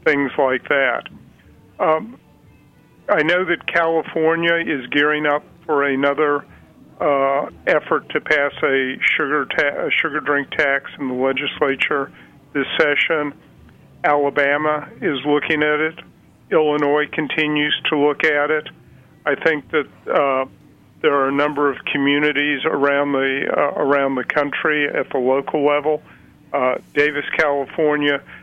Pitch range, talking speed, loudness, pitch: 140-150 Hz, 135 wpm, -18 LUFS, 145 Hz